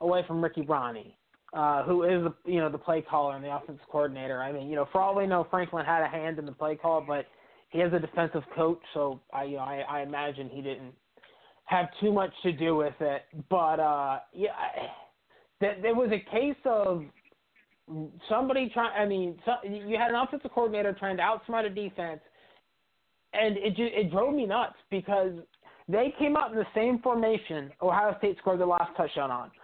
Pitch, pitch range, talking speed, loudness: 175 Hz, 155-210 Hz, 205 wpm, -29 LUFS